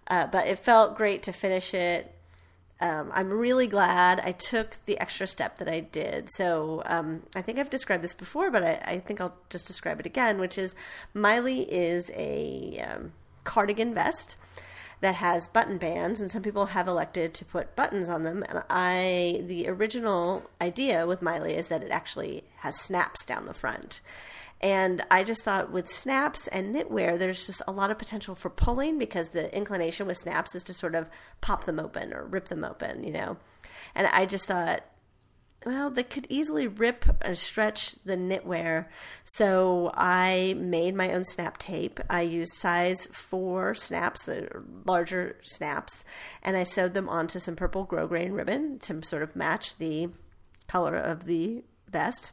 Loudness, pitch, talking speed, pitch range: -29 LUFS, 185 Hz, 175 wpm, 175-205 Hz